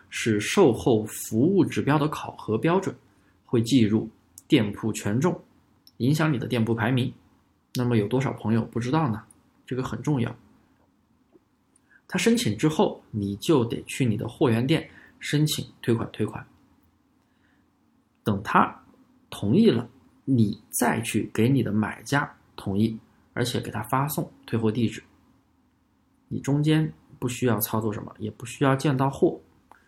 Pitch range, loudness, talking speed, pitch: 110-140 Hz, -25 LUFS, 210 characters per minute, 120 Hz